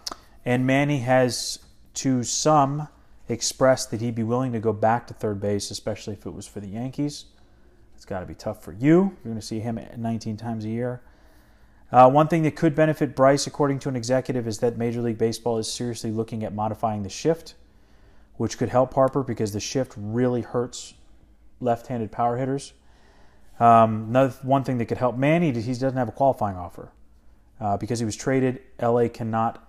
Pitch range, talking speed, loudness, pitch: 110-130 Hz, 195 wpm, -24 LUFS, 120 Hz